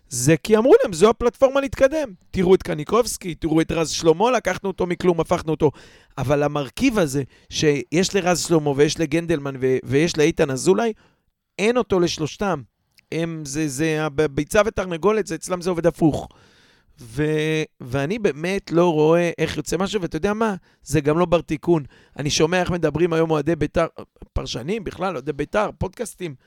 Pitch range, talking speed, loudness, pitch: 150-185 Hz, 160 wpm, -21 LUFS, 165 Hz